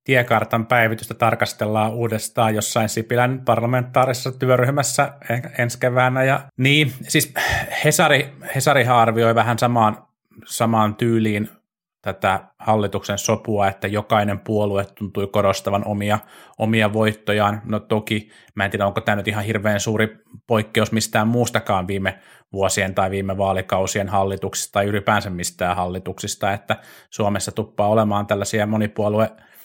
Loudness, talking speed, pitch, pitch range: -20 LUFS, 125 wpm, 110 Hz, 100-120 Hz